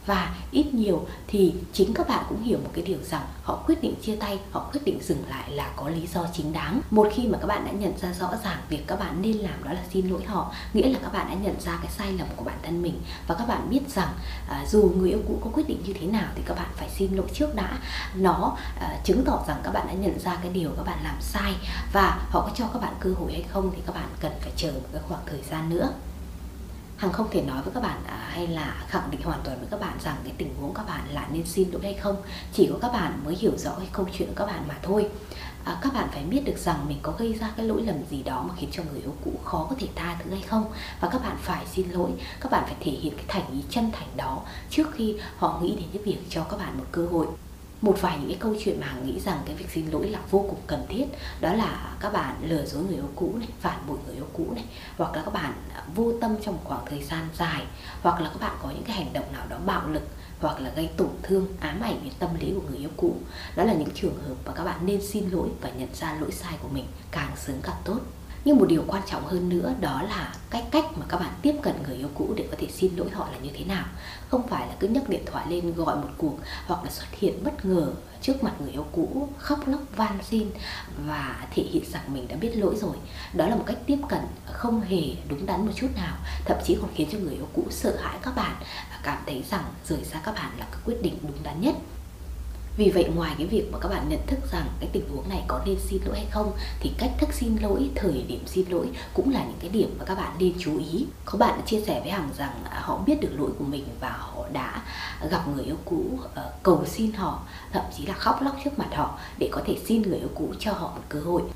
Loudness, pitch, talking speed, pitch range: -28 LUFS, 190 Hz, 275 wpm, 170-220 Hz